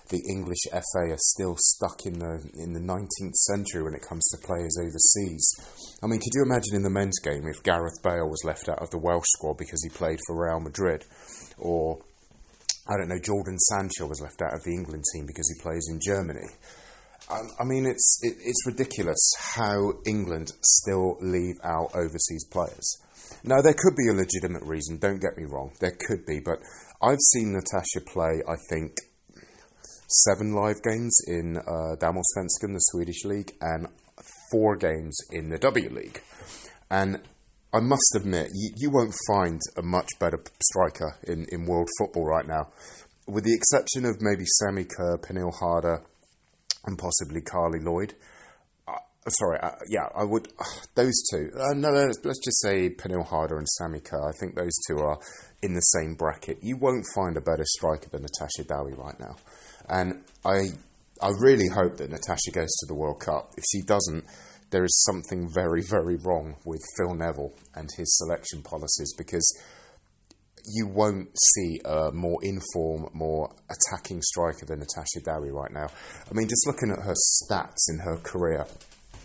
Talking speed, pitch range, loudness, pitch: 175 wpm, 80-100 Hz, -23 LUFS, 90 Hz